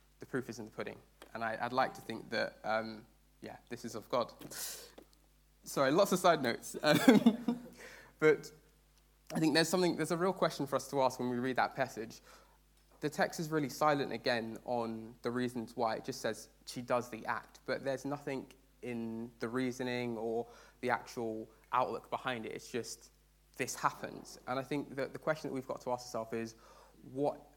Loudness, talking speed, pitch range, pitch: -35 LUFS, 195 wpm, 115-150 Hz, 130 Hz